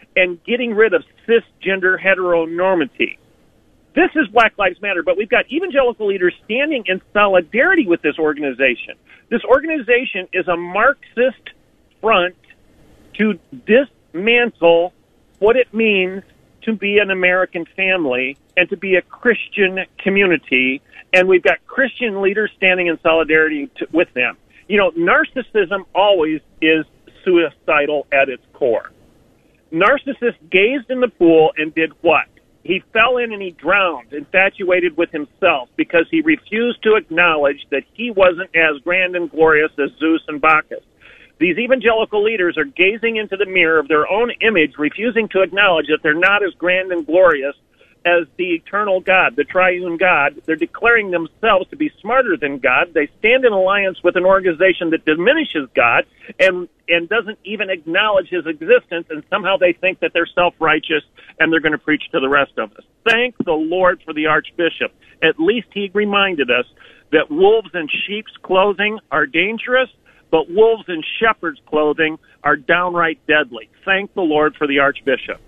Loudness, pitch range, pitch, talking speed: -16 LUFS, 160-220 Hz, 185 Hz, 160 wpm